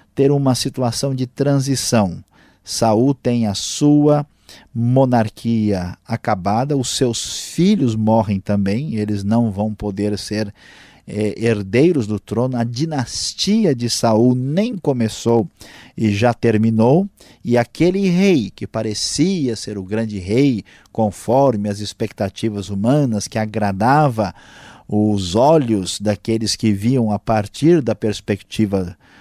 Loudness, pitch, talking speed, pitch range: -18 LUFS, 115 Hz, 120 wpm, 105-130 Hz